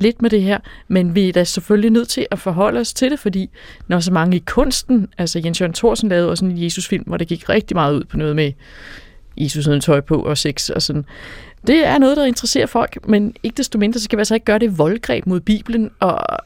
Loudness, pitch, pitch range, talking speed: -17 LUFS, 195 Hz, 170-230 Hz, 250 wpm